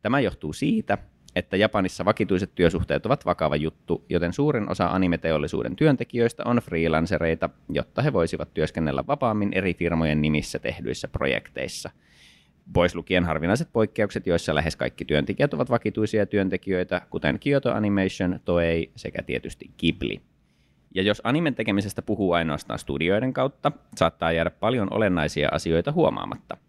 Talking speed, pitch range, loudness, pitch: 135 wpm, 85-110 Hz, -25 LUFS, 95 Hz